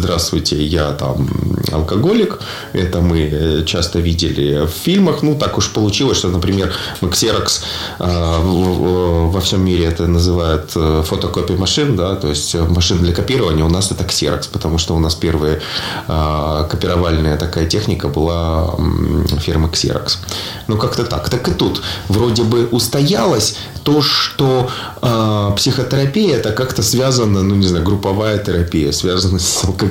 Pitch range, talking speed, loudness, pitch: 85-105 Hz, 140 wpm, -15 LUFS, 90 Hz